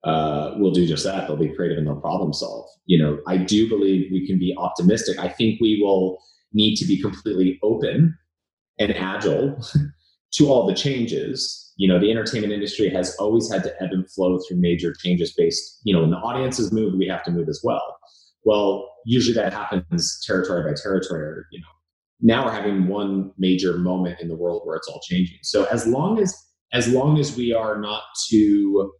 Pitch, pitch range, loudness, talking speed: 95 Hz, 90-115 Hz, -21 LUFS, 205 wpm